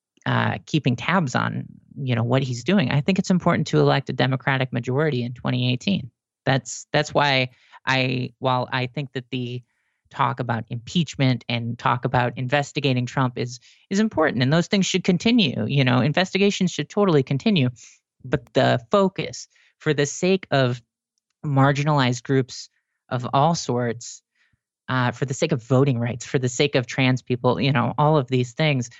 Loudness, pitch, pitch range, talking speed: -22 LUFS, 135 Hz, 125-155 Hz, 170 wpm